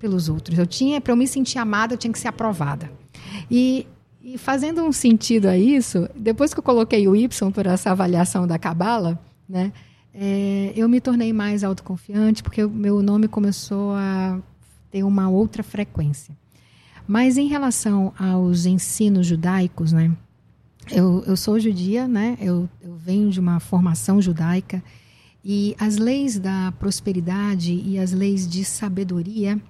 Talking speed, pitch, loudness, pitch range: 155 wpm, 195 Hz, -20 LUFS, 180-225 Hz